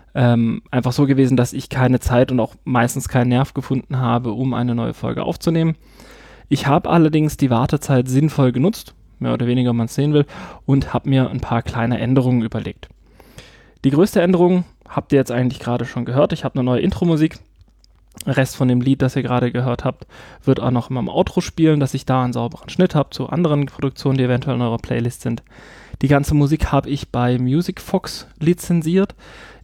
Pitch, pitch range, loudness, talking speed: 130 Hz, 120-145 Hz, -18 LUFS, 200 wpm